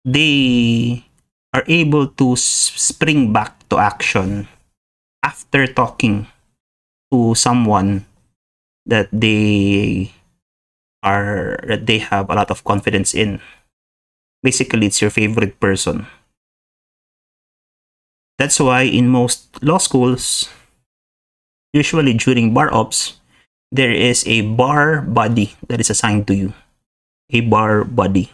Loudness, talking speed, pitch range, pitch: -15 LUFS, 110 wpm, 100-125 Hz, 110 Hz